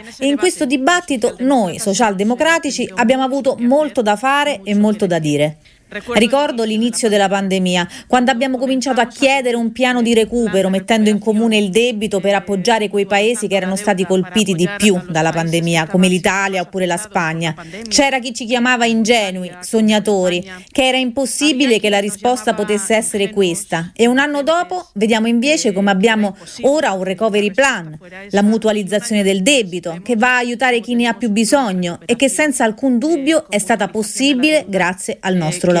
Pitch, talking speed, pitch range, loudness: 220 Hz, 170 wpm, 195-255 Hz, -15 LUFS